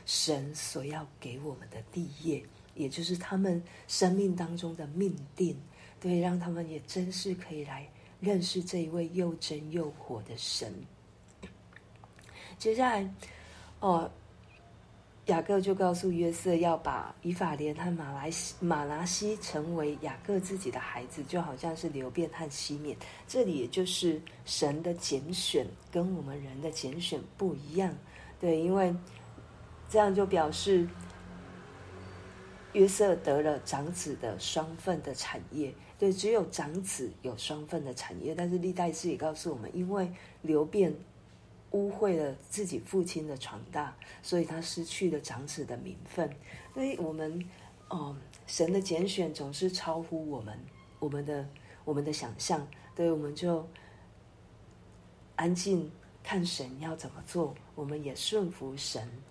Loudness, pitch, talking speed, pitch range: -33 LUFS, 160 Hz, 210 characters per minute, 140-180 Hz